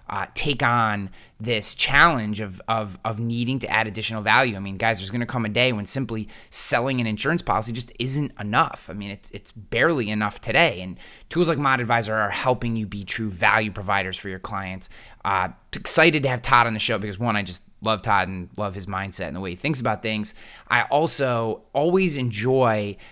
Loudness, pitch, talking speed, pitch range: -22 LUFS, 110 Hz, 215 wpm, 100-125 Hz